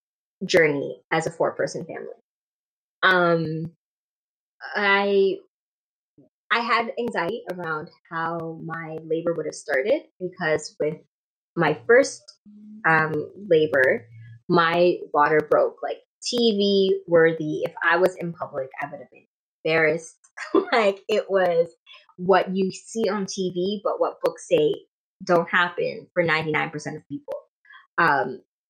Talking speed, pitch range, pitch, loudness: 125 wpm, 160-210 Hz, 180 Hz, -23 LUFS